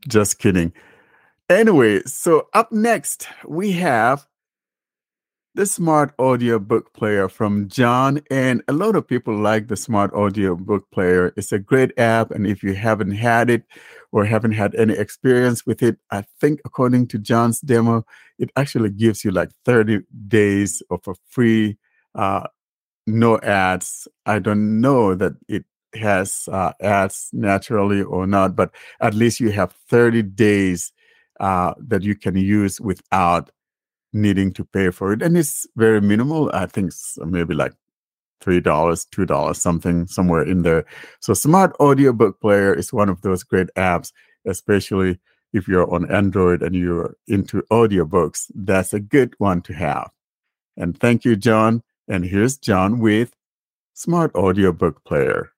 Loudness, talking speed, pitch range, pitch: -19 LUFS, 155 wpm, 95-120 Hz, 105 Hz